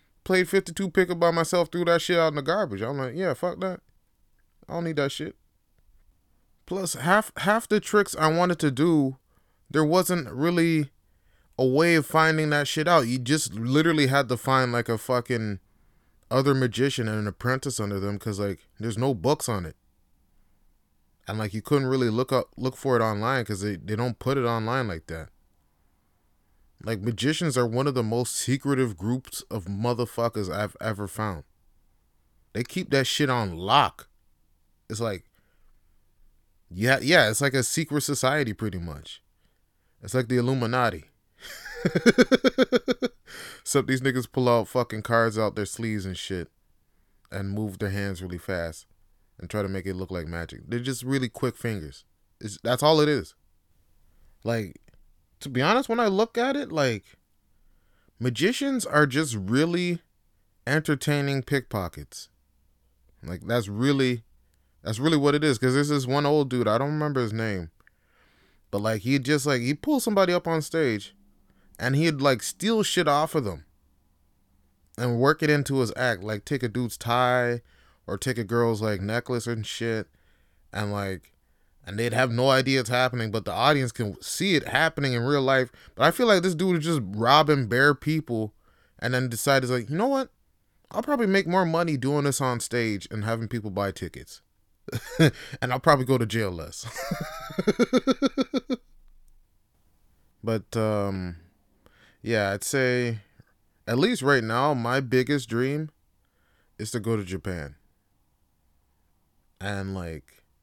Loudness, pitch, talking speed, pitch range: -25 LUFS, 120 Hz, 165 wpm, 95-145 Hz